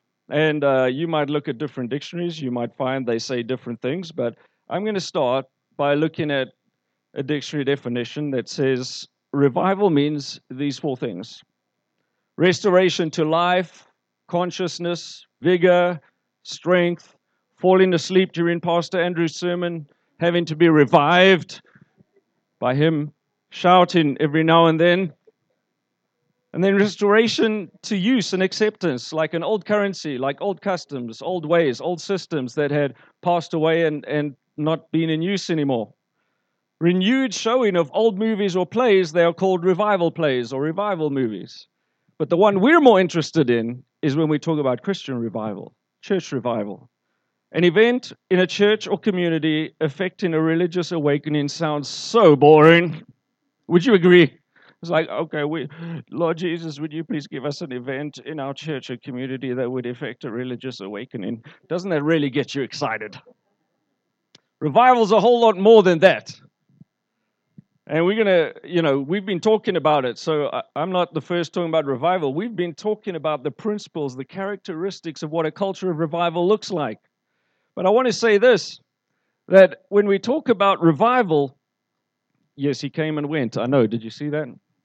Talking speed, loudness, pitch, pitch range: 160 wpm, -20 LUFS, 165 Hz, 140-185 Hz